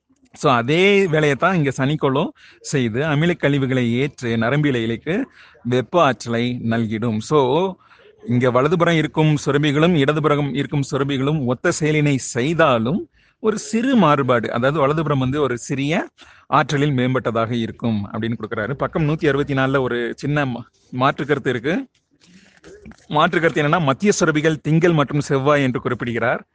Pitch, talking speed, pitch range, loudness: 145 Hz, 120 wpm, 125-160 Hz, -19 LUFS